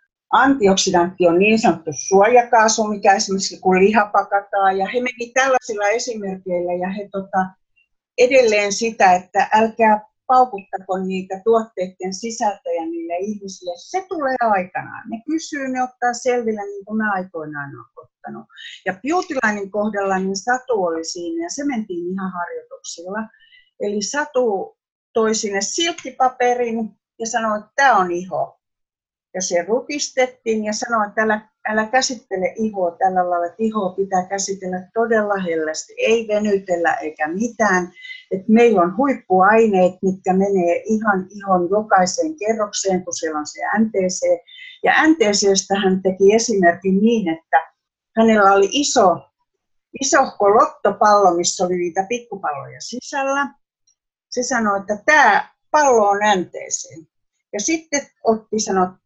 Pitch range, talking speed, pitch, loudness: 185-245 Hz, 130 wpm, 210 Hz, -18 LUFS